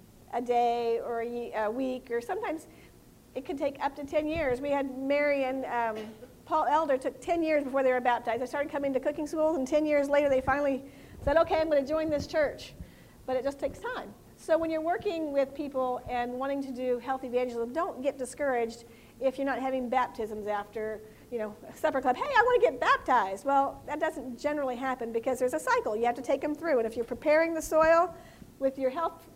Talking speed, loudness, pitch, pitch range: 225 wpm, -29 LUFS, 275 Hz, 250-310 Hz